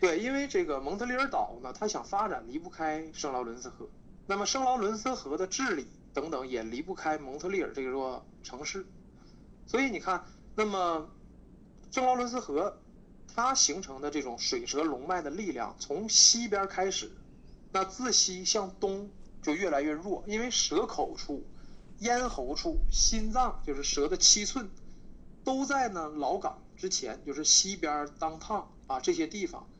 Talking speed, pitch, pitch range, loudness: 245 characters per minute, 195 Hz, 160-250 Hz, -30 LUFS